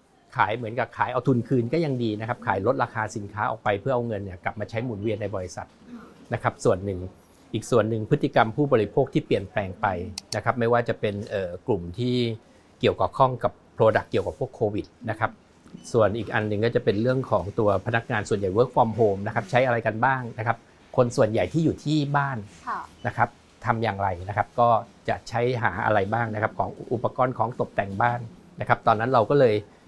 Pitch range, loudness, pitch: 105-125 Hz, -25 LUFS, 115 Hz